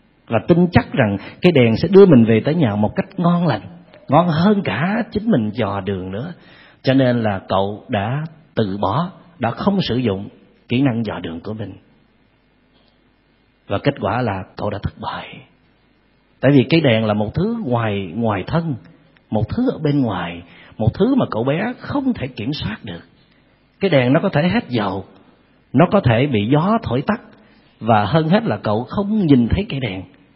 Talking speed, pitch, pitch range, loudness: 195 wpm, 125 Hz, 105-170 Hz, -18 LUFS